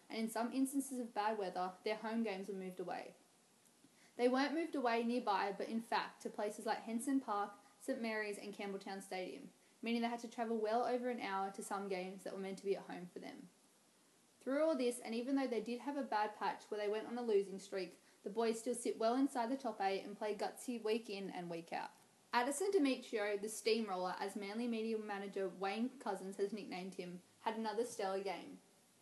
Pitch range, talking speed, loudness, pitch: 195-240 Hz, 215 wpm, -41 LUFS, 215 Hz